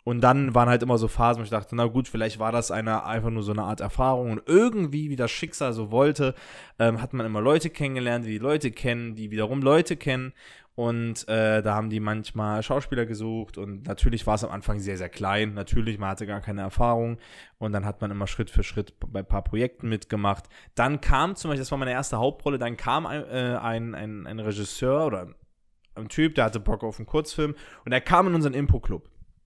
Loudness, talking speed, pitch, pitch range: -26 LUFS, 230 wpm, 115 Hz, 105-130 Hz